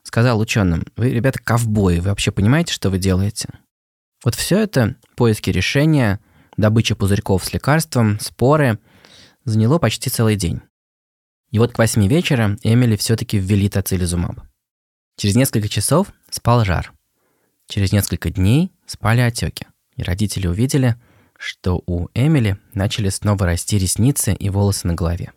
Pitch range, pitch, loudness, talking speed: 100-125 Hz, 105 Hz, -18 LUFS, 135 wpm